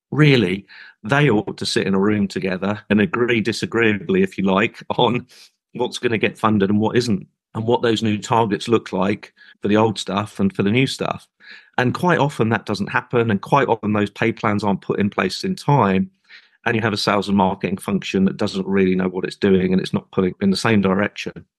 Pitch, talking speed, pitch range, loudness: 105 Hz, 225 wpm, 100-120 Hz, -19 LUFS